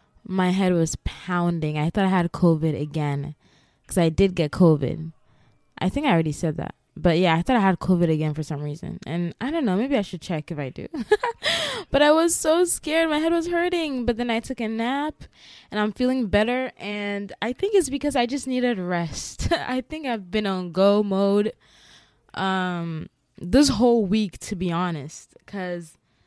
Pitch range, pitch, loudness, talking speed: 165-250 Hz, 190 Hz, -23 LUFS, 195 wpm